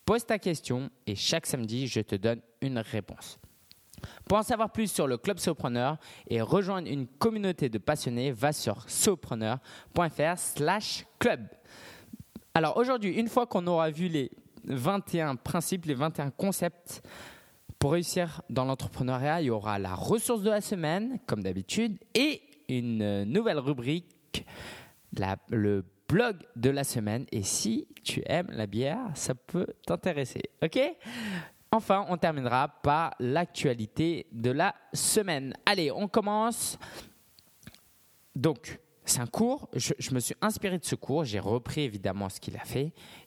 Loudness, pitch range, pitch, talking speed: -30 LUFS, 120-195 Hz, 150 Hz, 145 wpm